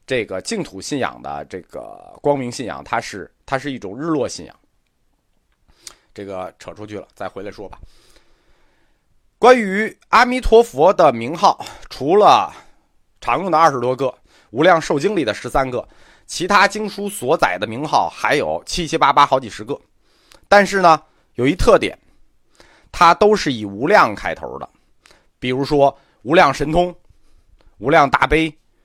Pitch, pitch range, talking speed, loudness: 155 Hz, 125-200 Hz, 225 characters per minute, -16 LUFS